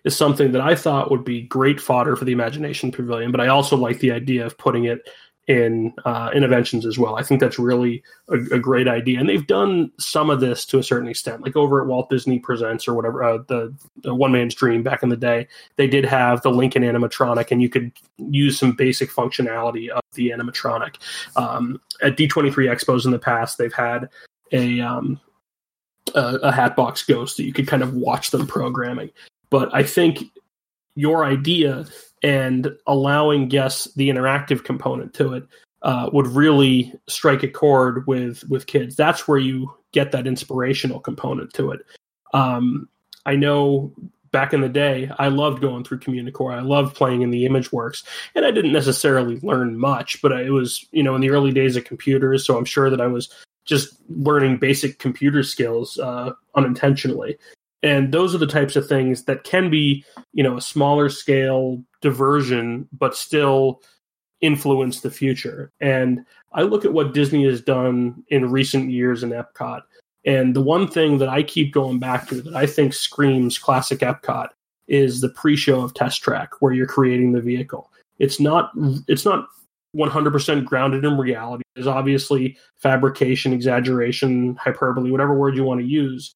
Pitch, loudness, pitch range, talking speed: 135 Hz, -19 LUFS, 125-140 Hz, 185 wpm